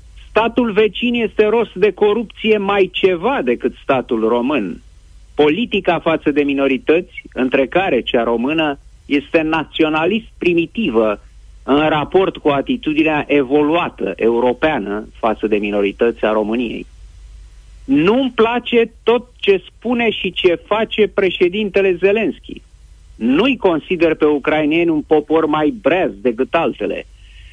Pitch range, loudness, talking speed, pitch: 130-210 Hz, -16 LUFS, 115 wpm, 160 Hz